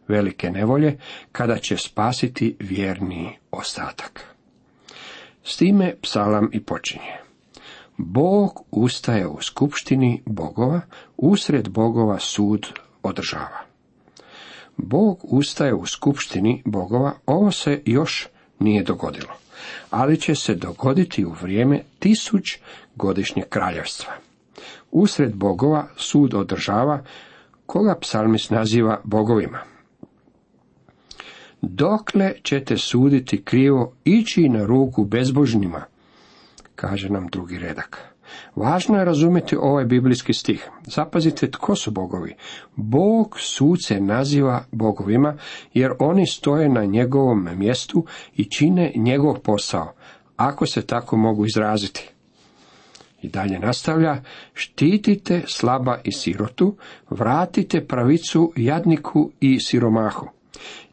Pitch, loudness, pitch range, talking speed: 125 Hz, -20 LUFS, 105-155 Hz, 100 wpm